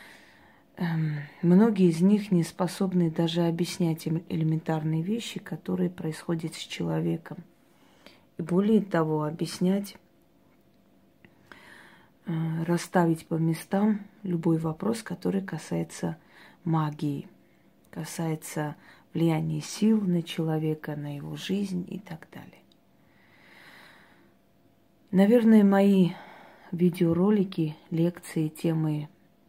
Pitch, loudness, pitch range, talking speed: 170 Hz, -27 LUFS, 160-190 Hz, 85 wpm